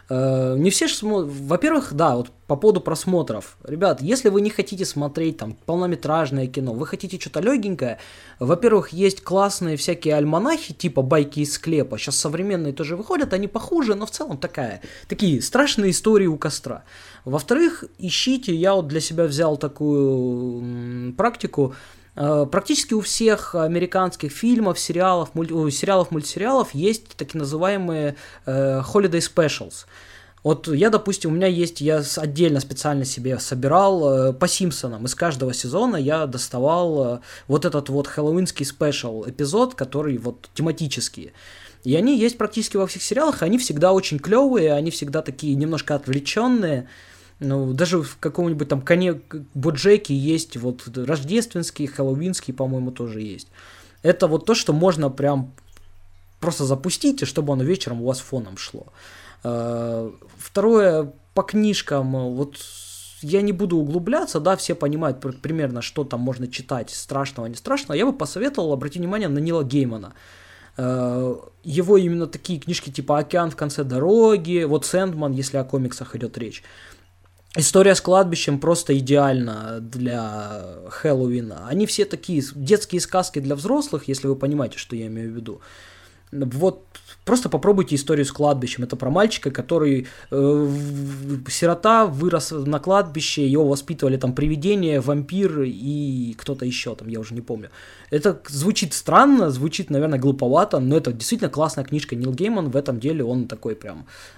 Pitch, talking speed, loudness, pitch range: 150 Hz, 150 wpm, -21 LUFS, 130-180 Hz